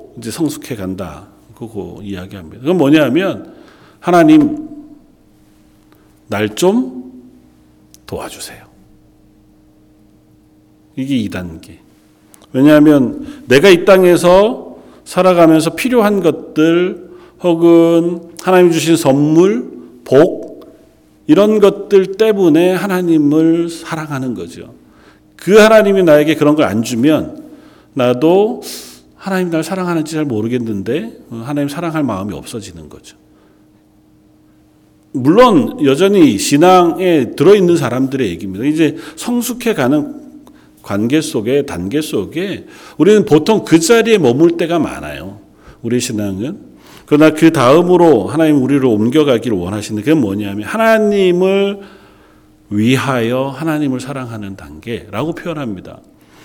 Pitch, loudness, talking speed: 155 Hz, -12 LUFS, 255 characters per minute